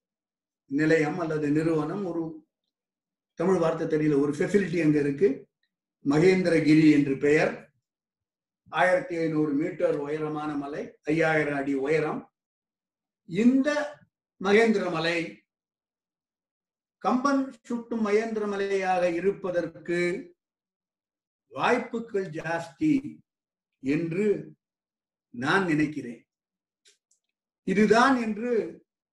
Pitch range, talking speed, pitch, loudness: 155-205 Hz, 75 wpm, 170 Hz, -26 LUFS